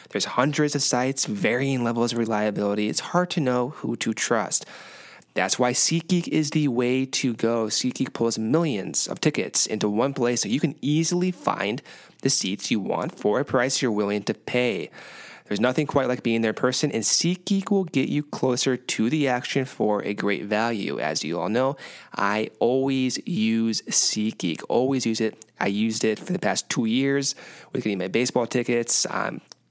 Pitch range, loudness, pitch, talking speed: 115-145 Hz, -24 LUFS, 125 Hz, 185 wpm